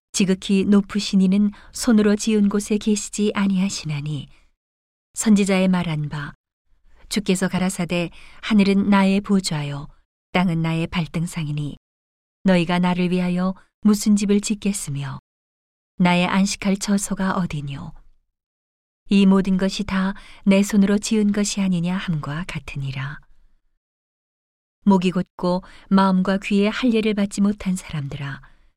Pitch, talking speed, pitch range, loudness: 185 Hz, 260 characters per minute, 150-200 Hz, -21 LUFS